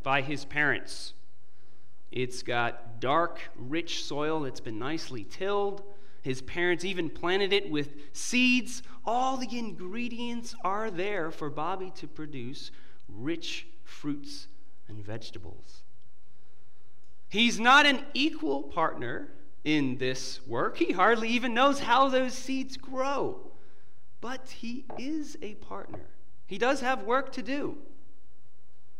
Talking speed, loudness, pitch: 120 wpm, -29 LUFS, 175 Hz